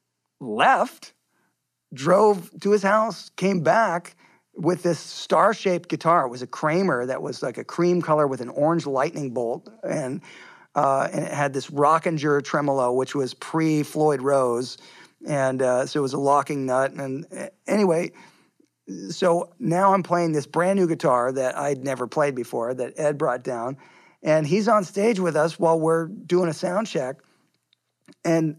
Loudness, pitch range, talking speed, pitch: -23 LUFS, 135-175 Hz, 165 wpm, 155 Hz